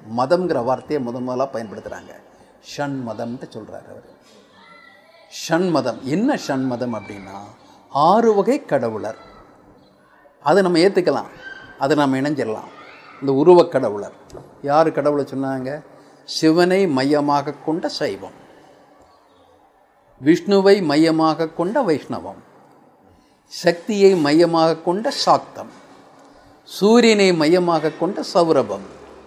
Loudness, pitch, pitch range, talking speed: -18 LUFS, 160 Hz, 135-180 Hz, 60 wpm